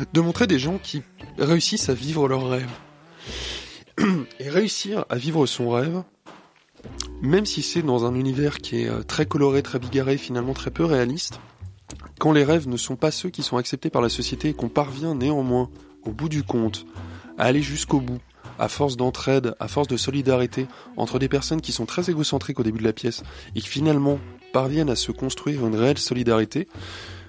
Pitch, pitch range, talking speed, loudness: 135 Hz, 120-150 Hz, 190 wpm, -23 LUFS